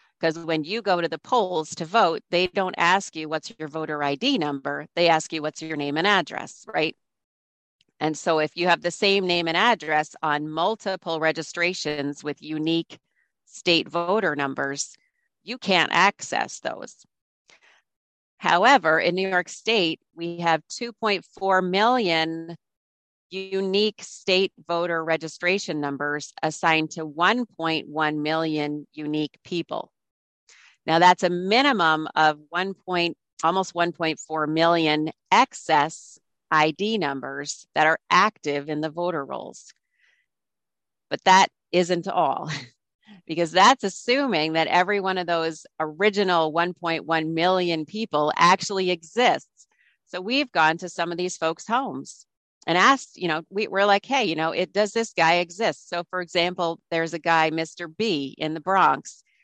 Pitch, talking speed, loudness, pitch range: 170 Hz, 145 wpm, -23 LUFS, 155-190 Hz